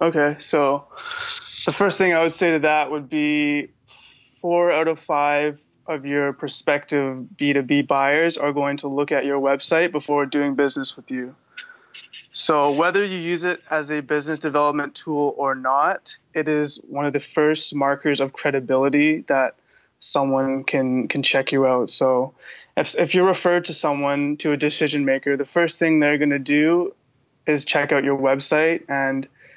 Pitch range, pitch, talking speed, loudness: 140-160 Hz, 145 Hz, 170 wpm, -21 LUFS